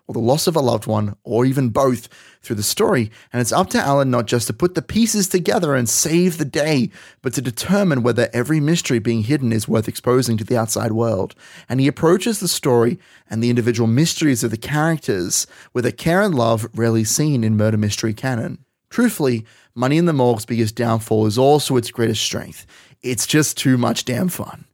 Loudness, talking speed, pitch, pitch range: -18 LUFS, 205 wpm, 125 Hz, 115-150 Hz